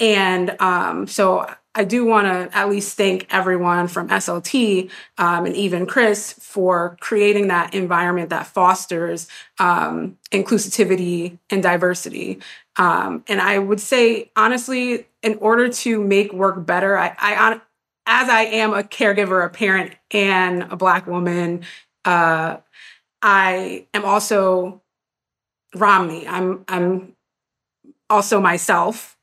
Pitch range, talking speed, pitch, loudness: 180-210 Hz, 125 wpm, 190 Hz, -18 LUFS